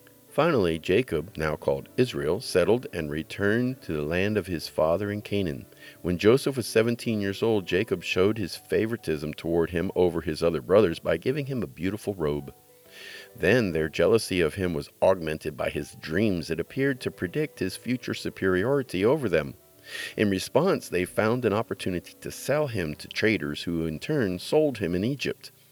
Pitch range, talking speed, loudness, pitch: 80-115 Hz, 175 wpm, -27 LUFS, 95 Hz